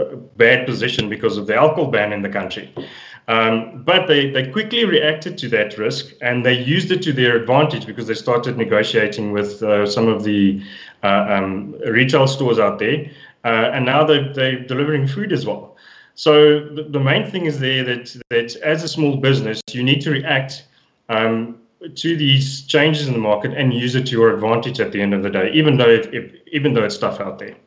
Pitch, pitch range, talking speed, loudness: 125 Hz, 115-145 Hz, 210 wpm, -17 LUFS